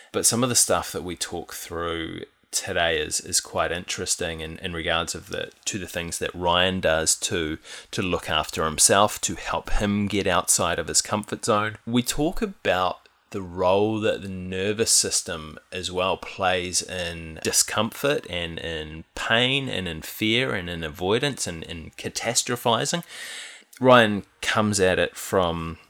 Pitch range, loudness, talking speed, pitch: 85-110 Hz, -23 LUFS, 160 wpm, 95 Hz